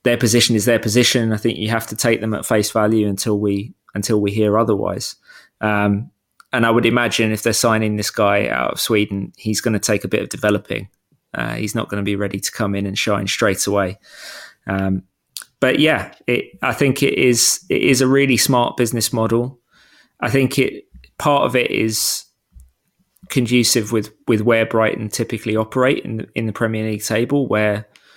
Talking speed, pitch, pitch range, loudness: 200 wpm, 110 Hz, 105-120 Hz, -18 LUFS